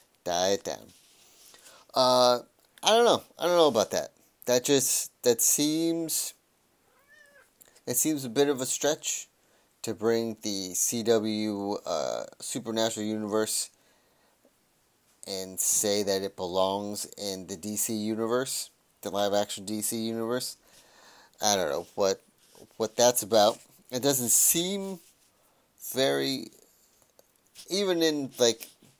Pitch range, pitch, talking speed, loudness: 105-130 Hz, 115 Hz, 120 wpm, -27 LUFS